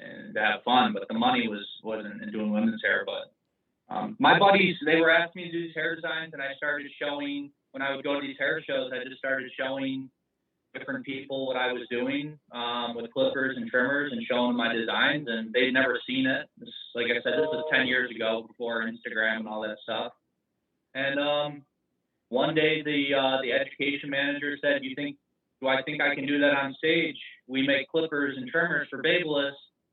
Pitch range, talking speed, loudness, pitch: 125-155 Hz, 215 wpm, -27 LUFS, 140 Hz